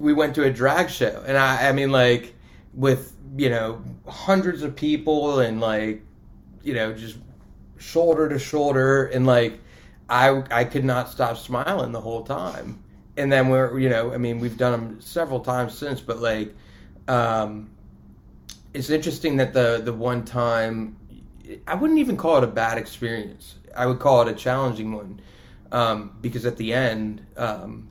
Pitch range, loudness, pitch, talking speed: 115-135 Hz, -22 LUFS, 125 Hz, 170 wpm